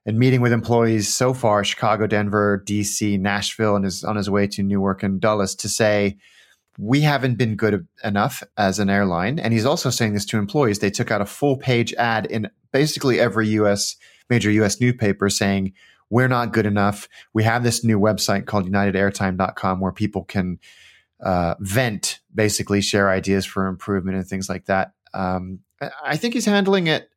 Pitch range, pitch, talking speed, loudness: 100-115 Hz, 105 Hz, 180 wpm, -20 LUFS